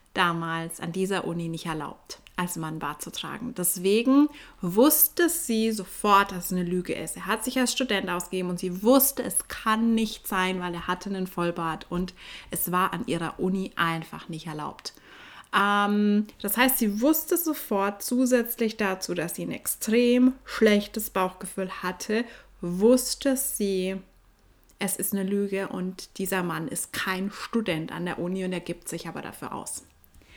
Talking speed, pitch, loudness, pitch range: 165 wpm, 190 Hz, -26 LUFS, 175-225 Hz